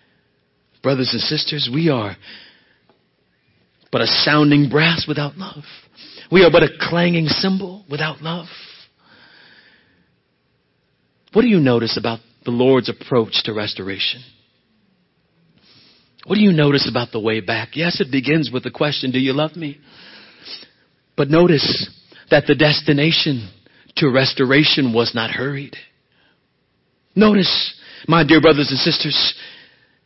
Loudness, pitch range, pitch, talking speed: -16 LUFS, 125-160 Hz, 145 Hz, 125 wpm